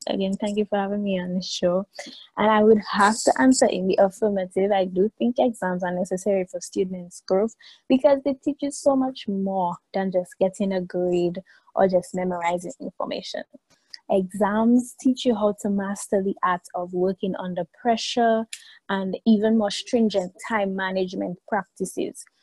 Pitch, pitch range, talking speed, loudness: 200 Hz, 185-225 Hz, 165 wpm, -23 LUFS